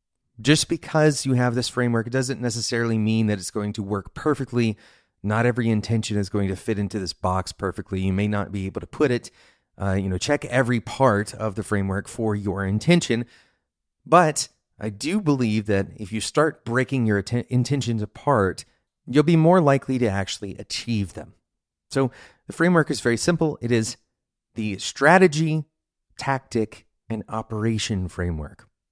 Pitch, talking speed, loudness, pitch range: 115 Hz, 170 wpm, -23 LUFS, 100-130 Hz